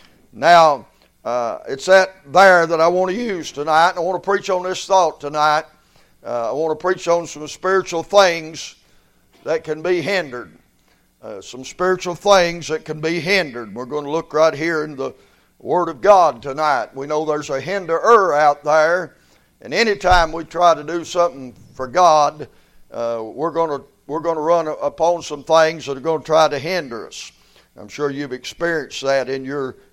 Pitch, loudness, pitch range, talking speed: 160 Hz, -17 LUFS, 145-175 Hz, 190 wpm